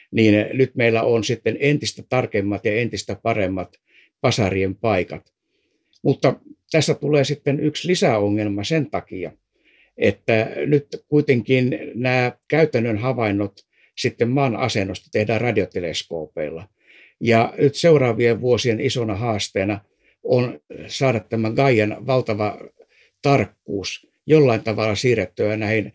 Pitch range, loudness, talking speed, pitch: 105-140 Hz, -20 LUFS, 110 wpm, 120 Hz